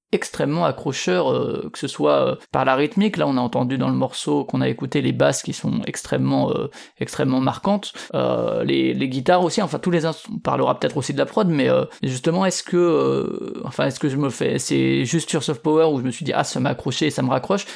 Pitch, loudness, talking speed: 145 Hz, -21 LUFS, 250 wpm